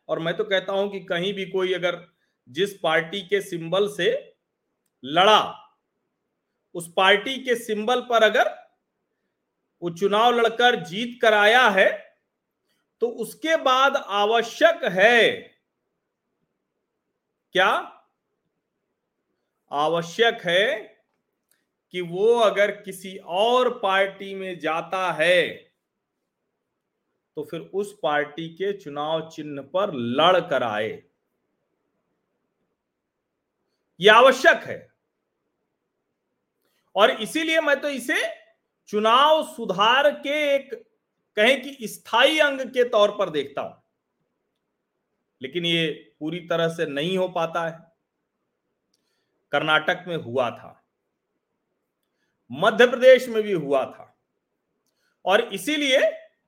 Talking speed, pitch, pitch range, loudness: 105 wpm, 200 Hz, 170-255 Hz, -21 LUFS